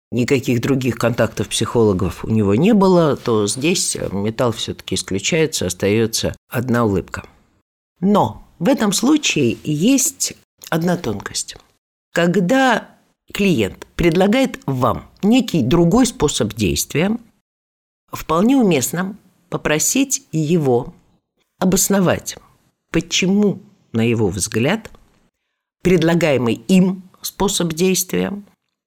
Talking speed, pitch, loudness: 90 wpm, 160 Hz, -17 LUFS